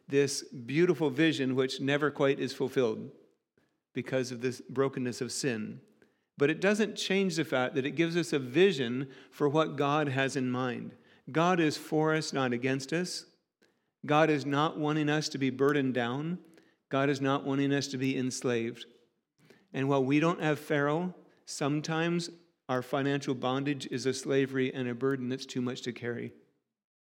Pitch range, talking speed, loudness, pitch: 130-155 Hz, 170 wpm, -30 LUFS, 140 Hz